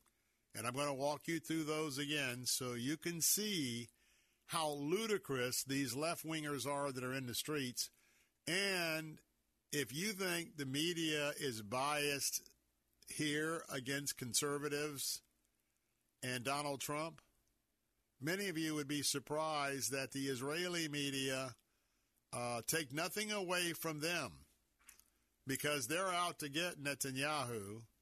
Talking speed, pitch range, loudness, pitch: 130 wpm, 135-160 Hz, -40 LUFS, 145 Hz